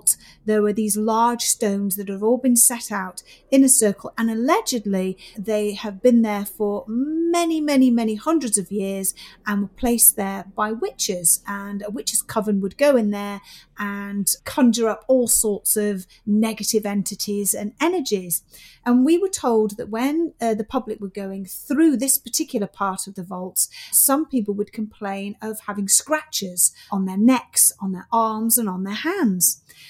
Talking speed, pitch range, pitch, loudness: 175 wpm, 200-245 Hz, 215 Hz, -20 LUFS